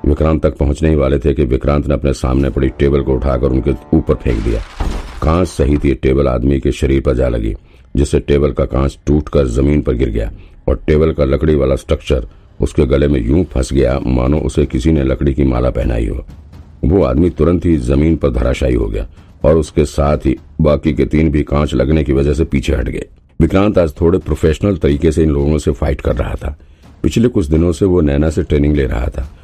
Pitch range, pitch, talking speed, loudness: 70-80 Hz, 75 Hz, 225 wpm, -14 LUFS